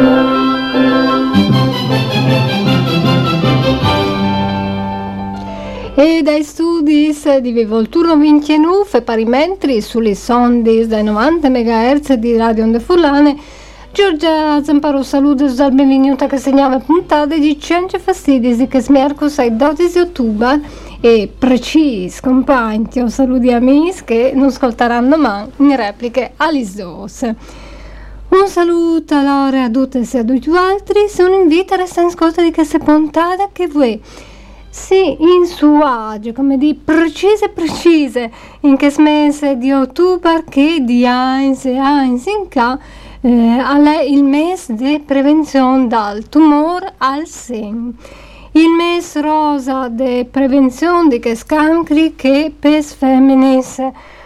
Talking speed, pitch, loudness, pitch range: 120 wpm, 275 Hz, -12 LUFS, 245-310 Hz